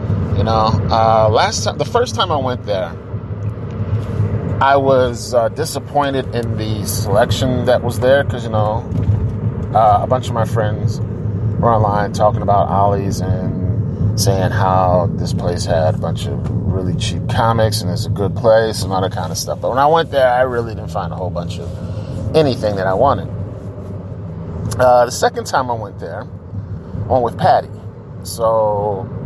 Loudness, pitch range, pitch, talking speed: -16 LUFS, 100-115 Hz, 105 Hz, 175 wpm